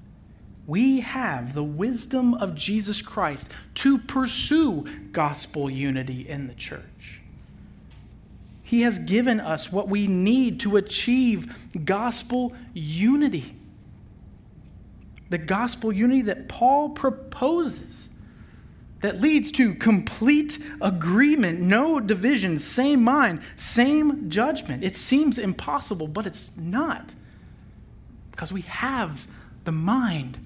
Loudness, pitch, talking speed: -23 LUFS, 205 Hz, 105 wpm